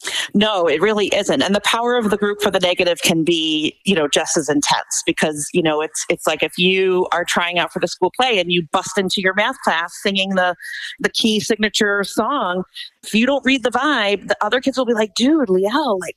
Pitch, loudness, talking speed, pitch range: 205 Hz, -17 LUFS, 235 wpm, 180-230 Hz